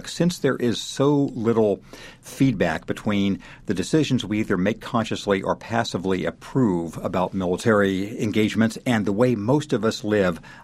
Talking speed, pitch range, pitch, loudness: 145 wpm, 100-125 Hz, 110 Hz, -23 LUFS